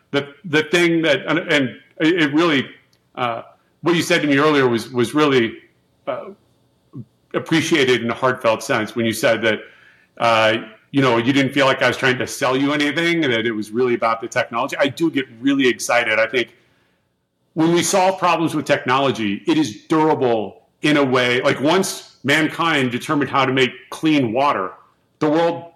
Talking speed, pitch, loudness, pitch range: 185 wpm, 140 Hz, -18 LUFS, 120-155 Hz